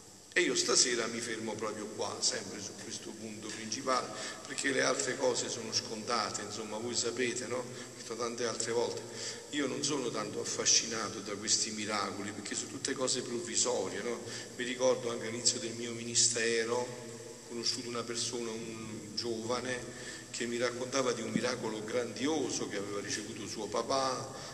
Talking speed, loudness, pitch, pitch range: 160 wpm, -33 LUFS, 120 Hz, 110-125 Hz